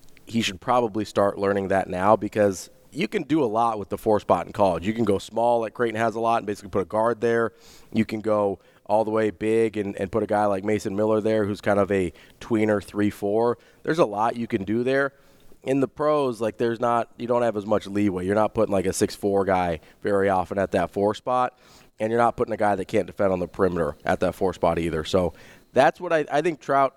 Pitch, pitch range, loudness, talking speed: 110 Hz, 100-115 Hz, -24 LUFS, 250 wpm